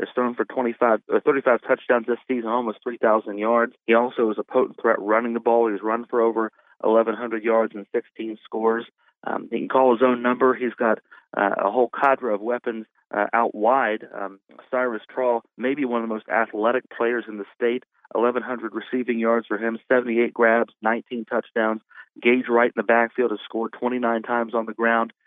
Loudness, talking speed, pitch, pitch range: -23 LUFS, 195 wpm, 115 Hz, 110-120 Hz